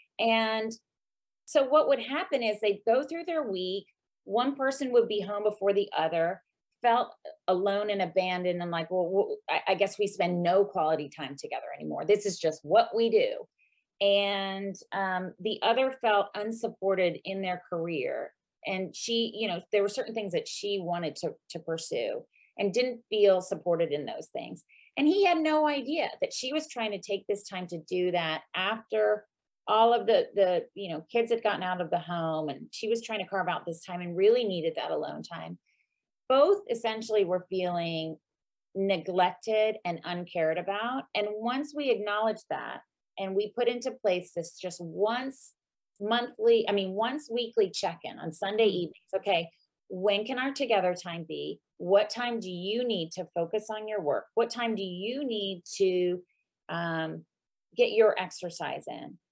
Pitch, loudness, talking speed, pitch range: 205 Hz, -29 LUFS, 175 wpm, 180-240 Hz